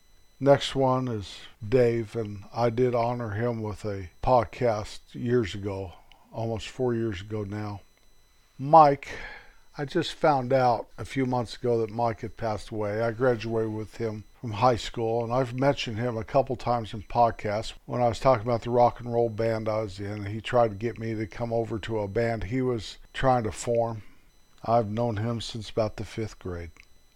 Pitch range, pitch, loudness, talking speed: 105-120 Hz, 115 Hz, -27 LUFS, 190 wpm